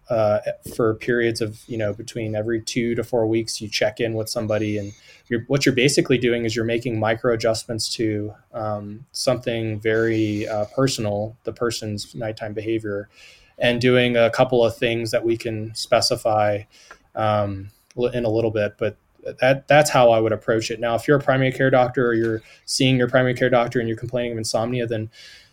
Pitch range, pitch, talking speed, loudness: 110-125 Hz, 115 Hz, 185 wpm, -21 LUFS